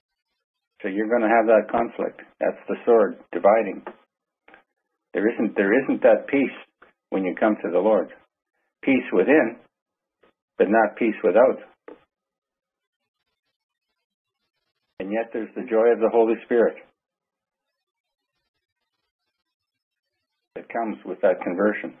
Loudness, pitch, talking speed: -22 LUFS, 115 Hz, 115 wpm